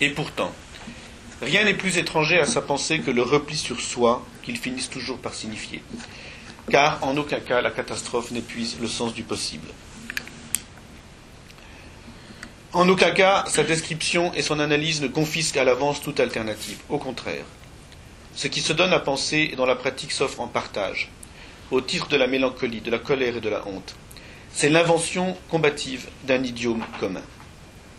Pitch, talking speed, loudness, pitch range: 140 Hz, 165 wpm, -23 LUFS, 120-160 Hz